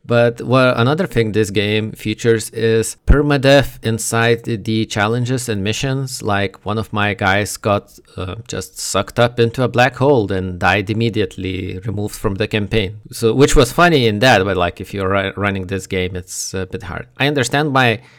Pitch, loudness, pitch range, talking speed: 110 Hz, -16 LUFS, 100-125 Hz, 180 wpm